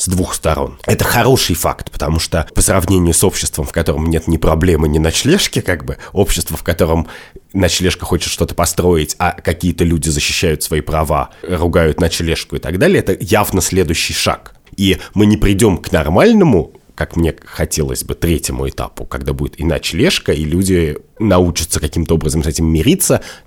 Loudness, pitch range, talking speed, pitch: -14 LUFS, 80-90 Hz, 170 wpm, 85 Hz